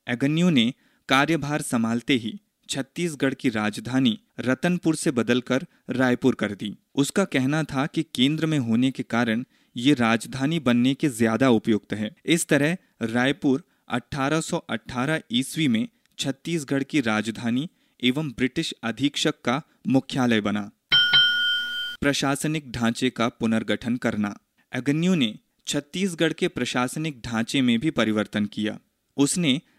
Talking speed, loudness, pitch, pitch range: 120 wpm, -24 LUFS, 135 Hz, 120-160 Hz